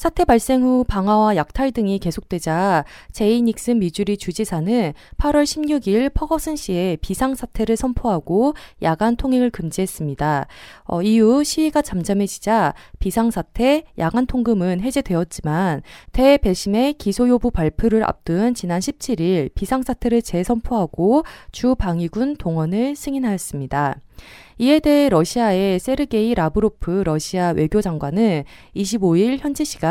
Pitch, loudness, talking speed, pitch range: 215 Hz, -19 LUFS, 300 characters per minute, 175-255 Hz